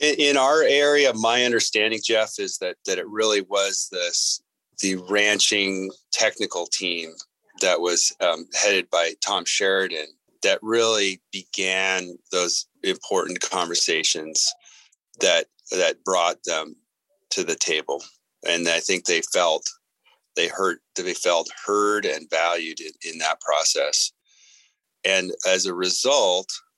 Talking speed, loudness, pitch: 130 wpm, -22 LUFS, 130 Hz